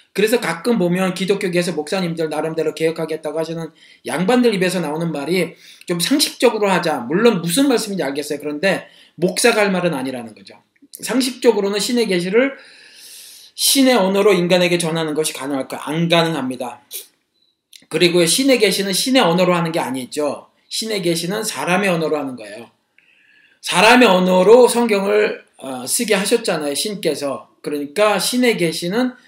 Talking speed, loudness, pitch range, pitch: 360 characters per minute, -17 LUFS, 160-225 Hz, 185 Hz